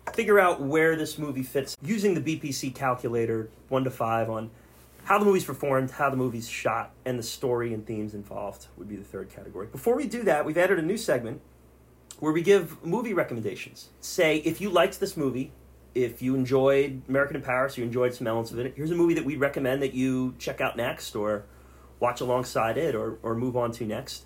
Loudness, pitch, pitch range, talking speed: -27 LUFS, 130 Hz, 115-150 Hz, 215 wpm